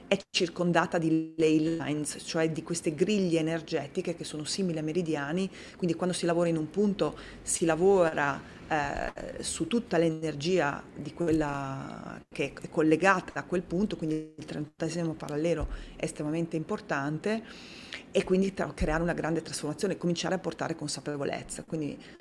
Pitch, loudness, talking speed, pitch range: 165 Hz, -30 LUFS, 150 wpm, 155-180 Hz